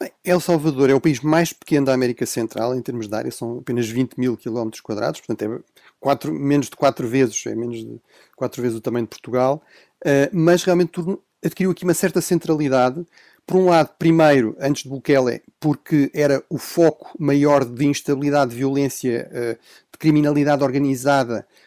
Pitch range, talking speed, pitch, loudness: 125-160 Hz, 180 wpm, 140 Hz, -20 LUFS